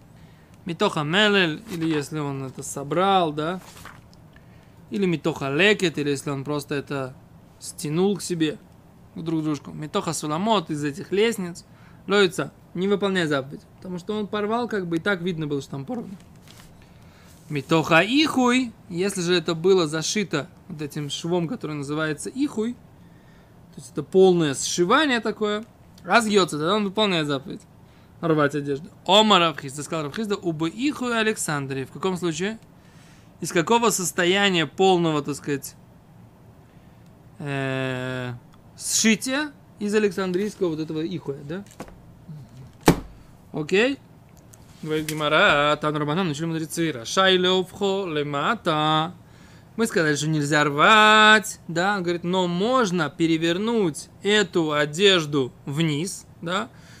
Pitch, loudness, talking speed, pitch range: 170 Hz, -22 LUFS, 120 wpm, 150-200 Hz